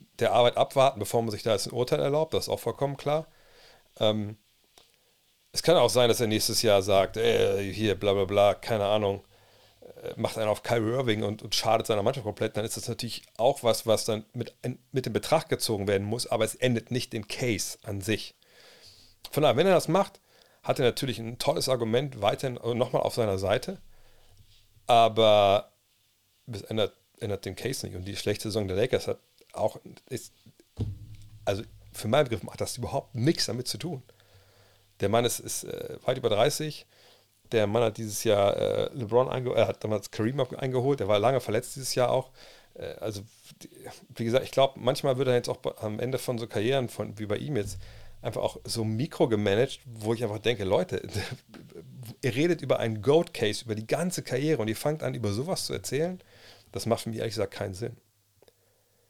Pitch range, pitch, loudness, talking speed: 105-125 Hz, 115 Hz, -28 LUFS, 200 wpm